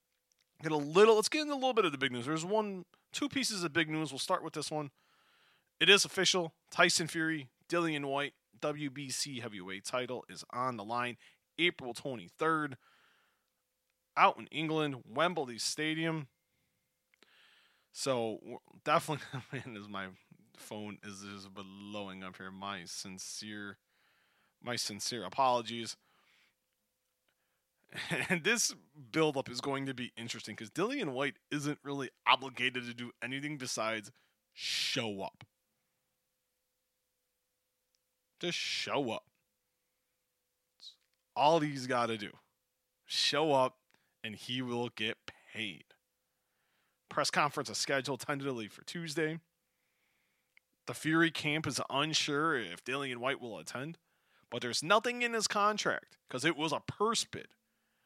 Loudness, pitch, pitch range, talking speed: -34 LUFS, 135 Hz, 115-160 Hz, 130 wpm